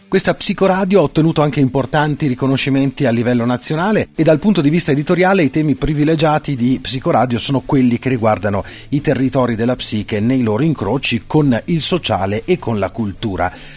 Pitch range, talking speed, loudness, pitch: 120-155 Hz, 170 wpm, -15 LUFS, 135 Hz